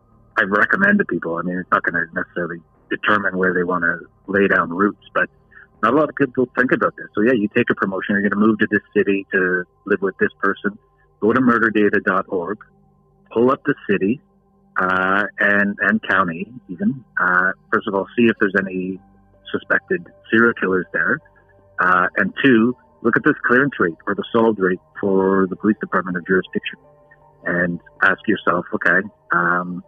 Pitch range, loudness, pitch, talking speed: 95-115 Hz, -19 LUFS, 100 Hz, 185 wpm